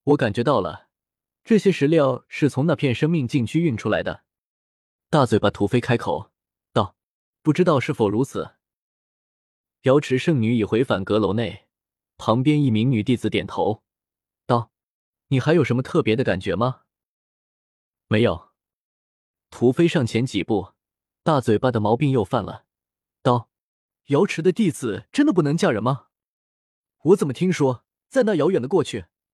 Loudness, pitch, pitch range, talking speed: -21 LUFS, 125 Hz, 105-150 Hz, 225 characters per minute